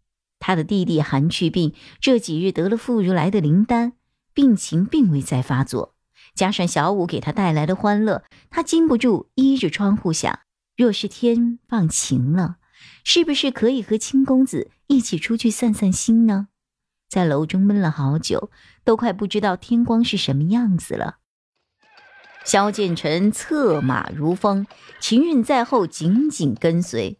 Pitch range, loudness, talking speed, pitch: 170-240 Hz, -20 LUFS, 225 characters per minute, 200 Hz